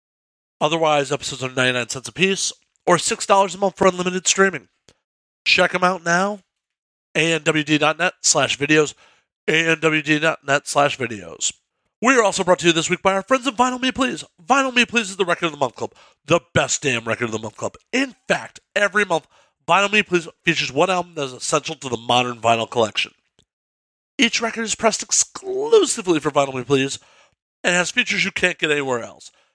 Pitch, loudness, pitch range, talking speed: 170 Hz, -19 LUFS, 140-195 Hz, 185 wpm